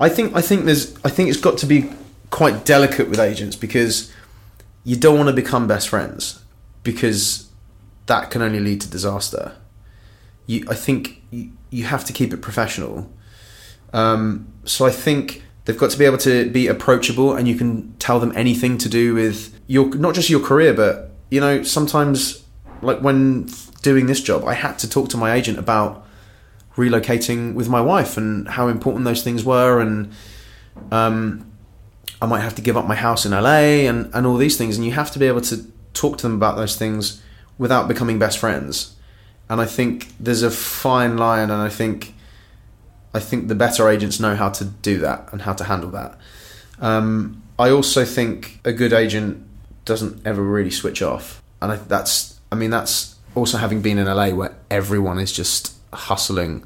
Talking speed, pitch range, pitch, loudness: 190 wpm, 105-125 Hz, 110 Hz, -18 LUFS